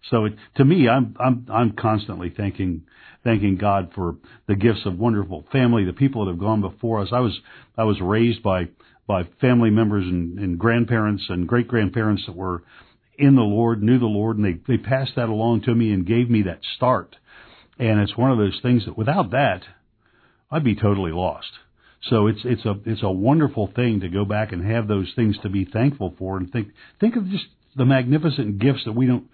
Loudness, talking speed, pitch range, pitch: -21 LUFS, 210 wpm, 100-120 Hz, 110 Hz